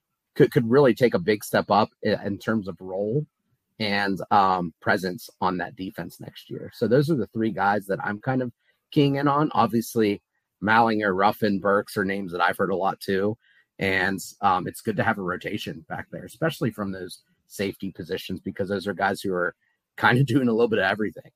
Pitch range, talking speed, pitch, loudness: 95-120 Hz, 210 wpm, 100 Hz, -24 LUFS